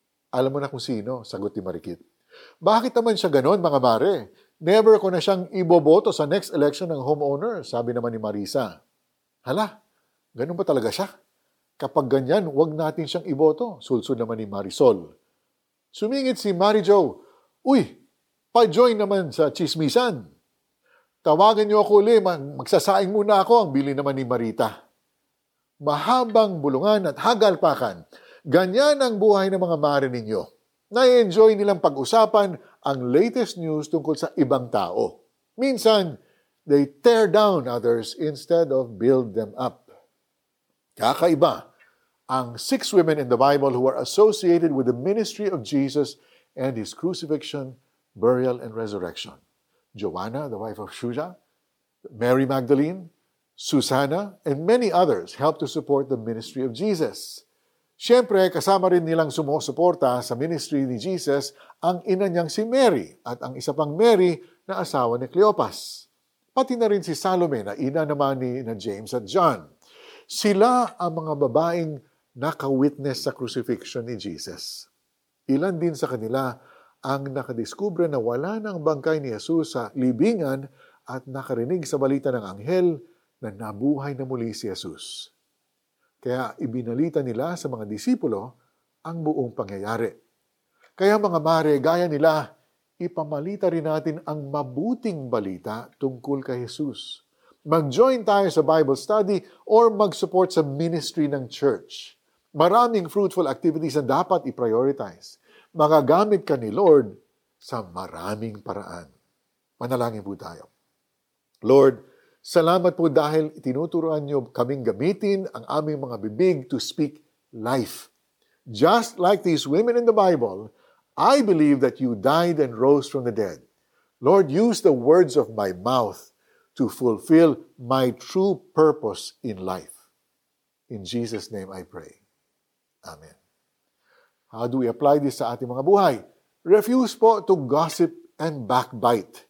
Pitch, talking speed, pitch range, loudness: 155 Hz, 140 wpm, 130-200 Hz, -22 LUFS